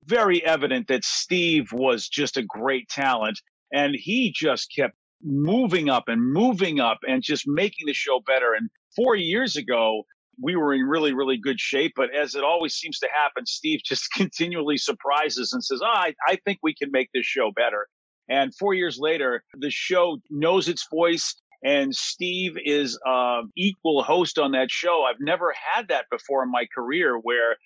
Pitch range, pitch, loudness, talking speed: 135-185 Hz, 150 Hz, -23 LUFS, 185 wpm